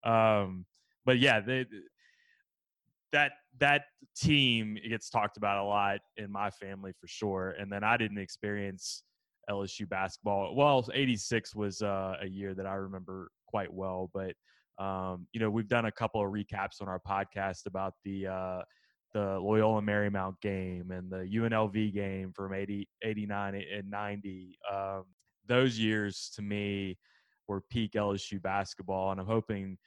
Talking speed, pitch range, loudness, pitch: 155 wpm, 95-110 Hz, -33 LUFS, 100 Hz